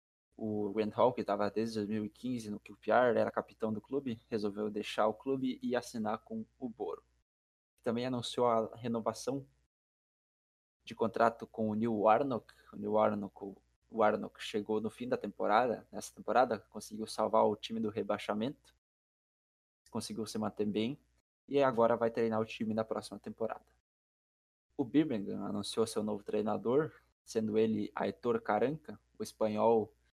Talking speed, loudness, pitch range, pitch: 145 wpm, -35 LUFS, 100-115 Hz, 110 Hz